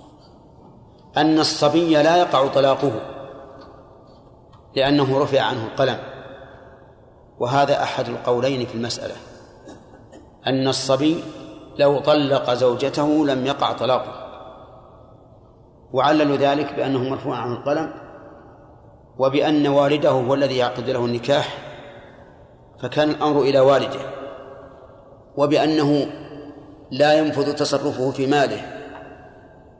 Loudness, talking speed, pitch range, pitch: -20 LUFS, 90 wpm, 130-145 Hz, 135 Hz